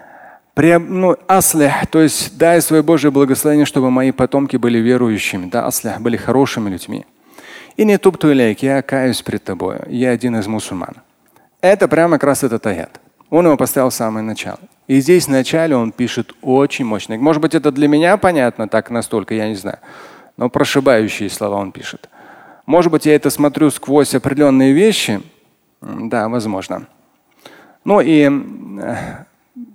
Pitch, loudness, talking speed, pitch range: 135 Hz, -14 LUFS, 160 wpm, 115-155 Hz